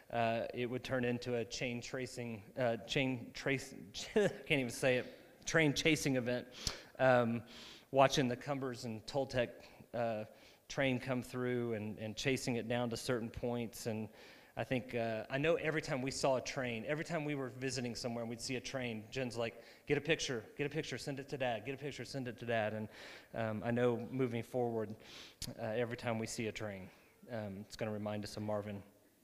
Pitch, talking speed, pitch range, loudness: 125 Hz, 205 wpm, 115-135 Hz, -38 LUFS